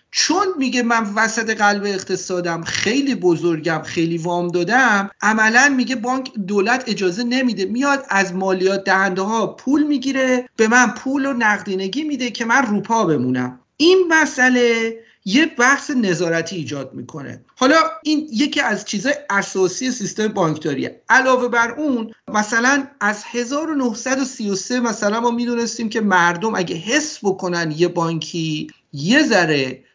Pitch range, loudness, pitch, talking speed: 185-260 Hz, -18 LUFS, 225 Hz, 135 wpm